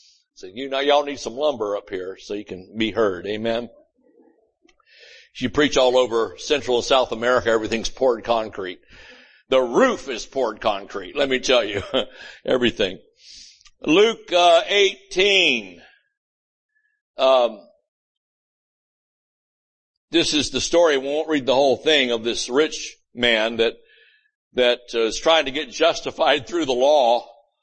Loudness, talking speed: -20 LUFS, 145 wpm